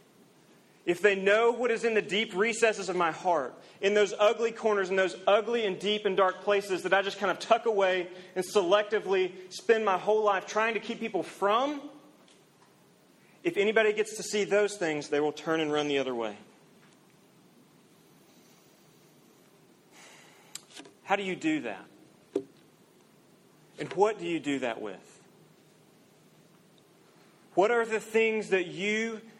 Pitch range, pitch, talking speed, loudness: 185-220 Hz, 200 Hz, 155 wpm, -28 LUFS